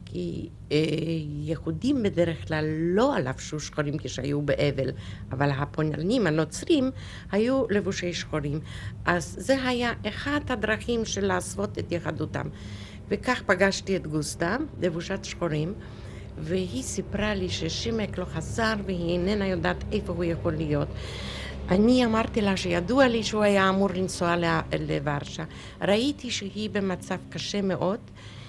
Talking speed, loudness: 125 wpm, -27 LUFS